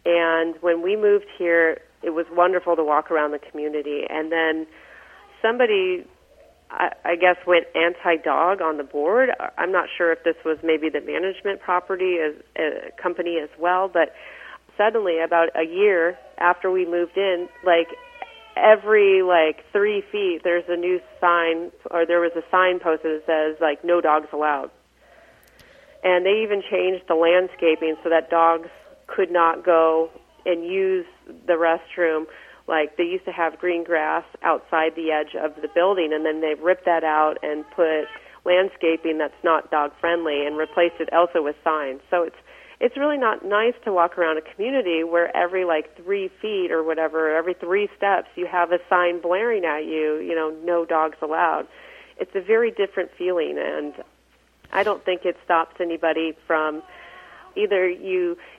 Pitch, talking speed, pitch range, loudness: 170 Hz, 170 wpm, 160-185 Hz, -22 LUFS